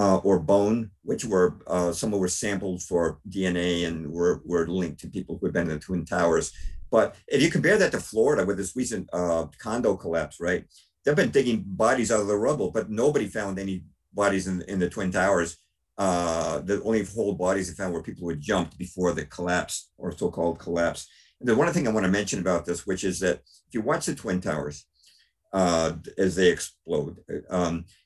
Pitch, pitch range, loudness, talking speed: 90 Hz, 85-95 Hz, -26 LUFS, 215 wpm